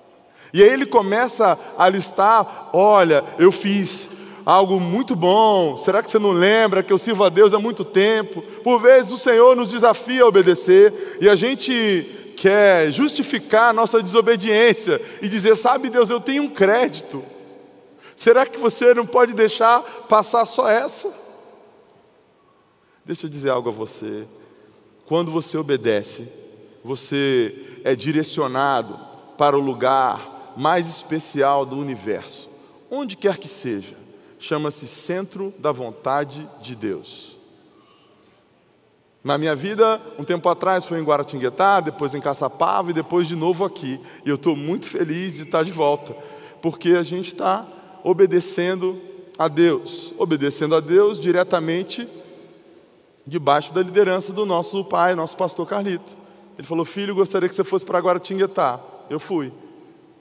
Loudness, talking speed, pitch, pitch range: -18 LUFS, 145 wpm, 195 Hz, 165-235 Hz